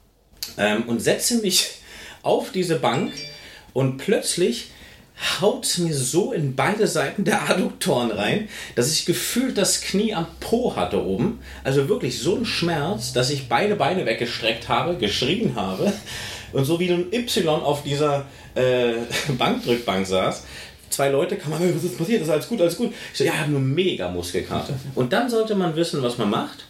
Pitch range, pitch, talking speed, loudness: 125-185 Hz, 155 Hz, 180 wpm, -22 LUFS